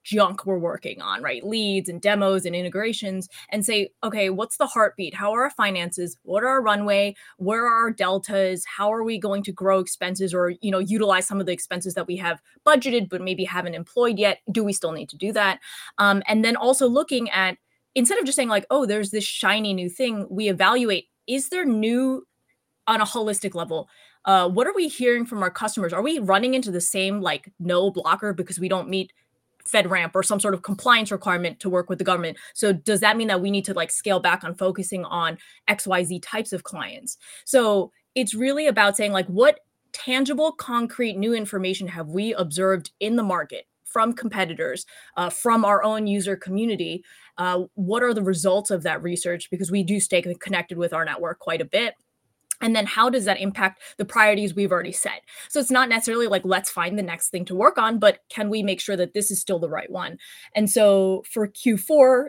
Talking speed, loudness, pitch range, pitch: 215 wpm, -22 LUFS, 185-225 Hz, 200 Hz